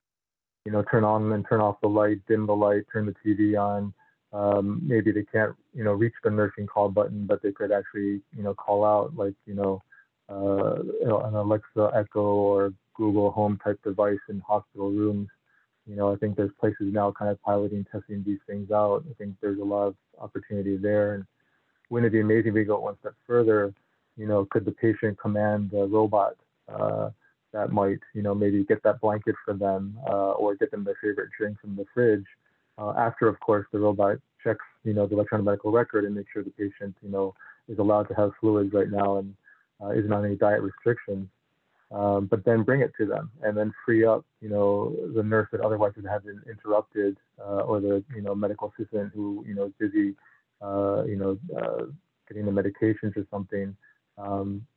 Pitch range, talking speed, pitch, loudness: 100-105 Hz, 205 wpm, 105 Hz, -26 LUFS